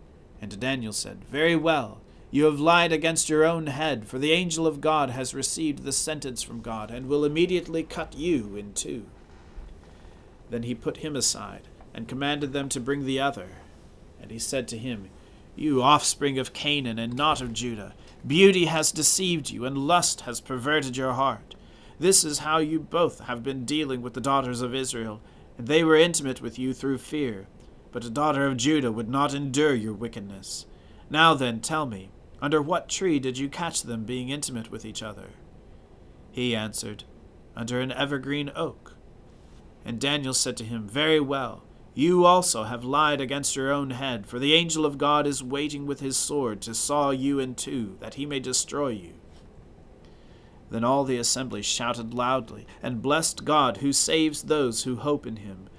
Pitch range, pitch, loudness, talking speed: 115-150 Hz, 135 Hz, -25 LUFS, 180 wpm